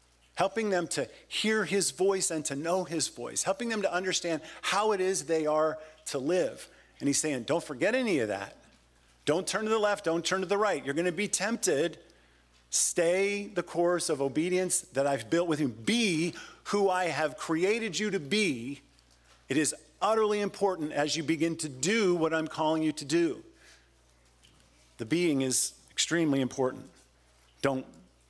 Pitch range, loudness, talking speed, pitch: 135-190 Hz, -29 LUFS, 180 wpm, 165 Hz